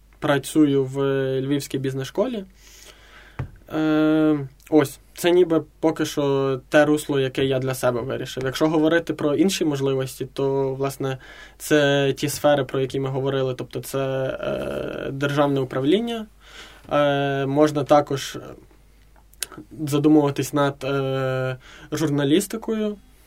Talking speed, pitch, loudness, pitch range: 105 wpm, 140 Hz, -22 LUFS, 135-155 Hz